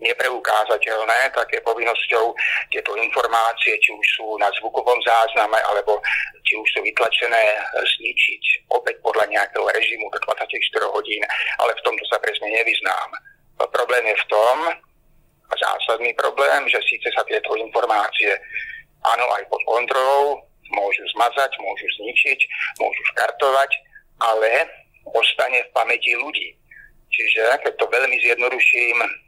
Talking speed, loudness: 130 wpm, -19 LUFS